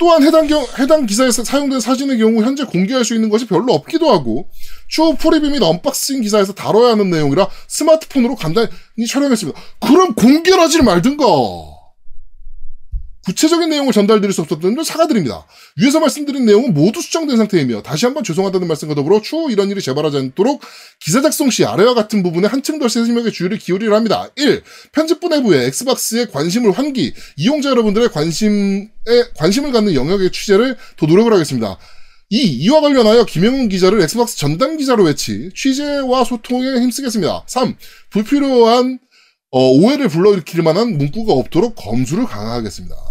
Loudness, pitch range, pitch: -14 LUFS, 185-270 Hz, 230 Hz